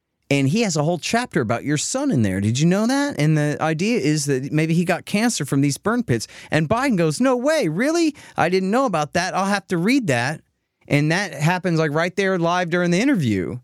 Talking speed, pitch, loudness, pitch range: 240 wpm, 175 Hz, -20 LUFS, 150-210 Hz